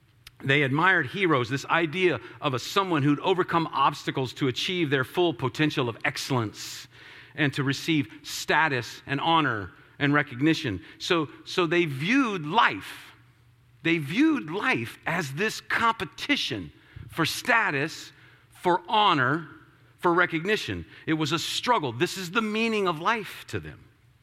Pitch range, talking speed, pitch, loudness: 135-180 Hz, 135 wpm, 155 Hz, -25 LUFS